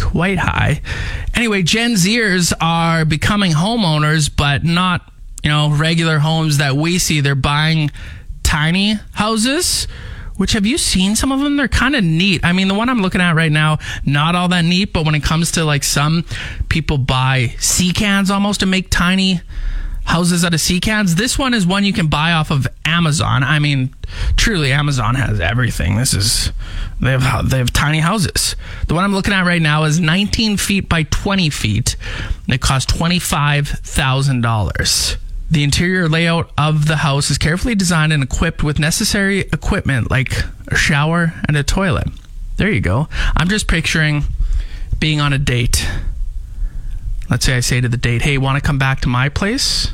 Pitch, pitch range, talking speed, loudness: 155 Hz, 130-180 Hz, 185 wpm, -15 LUFS